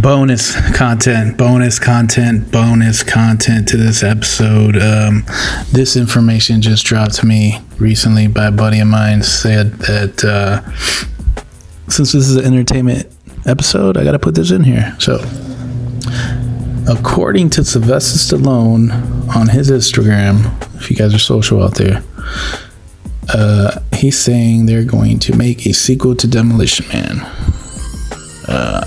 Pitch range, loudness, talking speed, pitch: 105-125 Hz, -11 LUFS, 135 wpm, 115 Hz